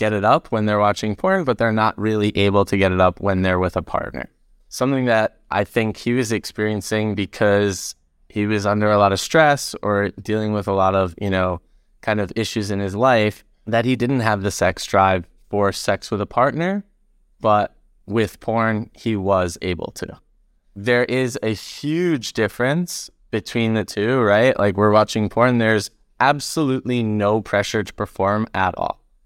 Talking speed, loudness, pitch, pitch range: 185 wpm, -20 LUFS, 105 Hz, 100-115 Hz